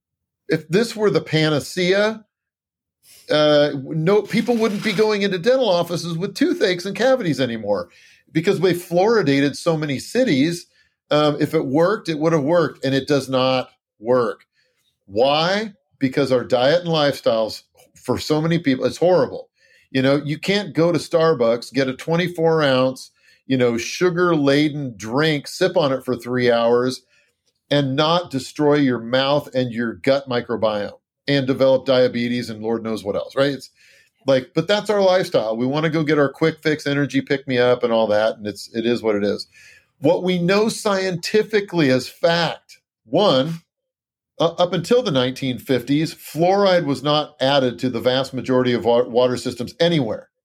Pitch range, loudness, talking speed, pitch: 130-175 Hz, -19 LUFS, 170 wpm, 145 Hz